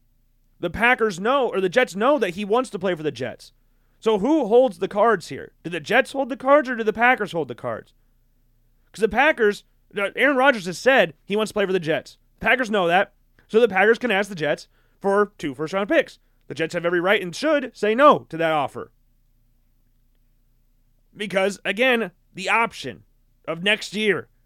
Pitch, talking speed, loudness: 195 Hz, 200 wpm, -21 LUFS